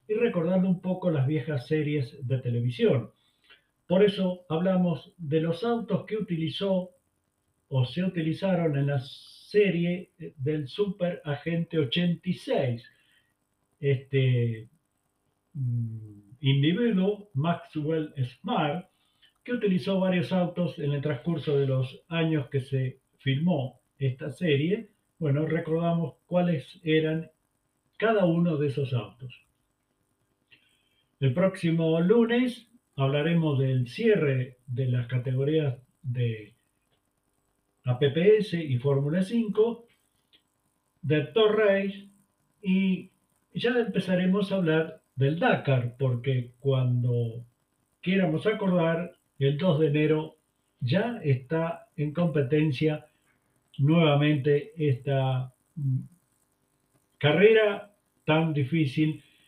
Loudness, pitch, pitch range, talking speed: -27 LUFS, 155 Hz, 135-180 Hz, 95 wpm